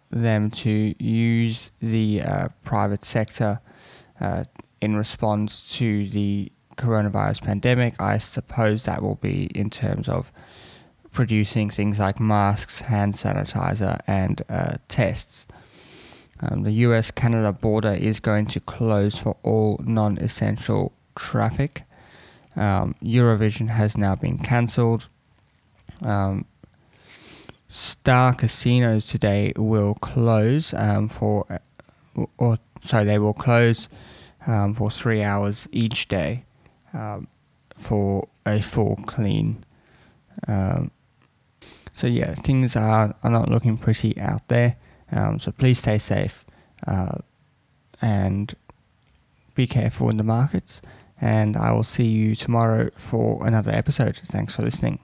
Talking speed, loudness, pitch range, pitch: 120 wpm, -23 LUFS, 105-120 Hz, 110 Hz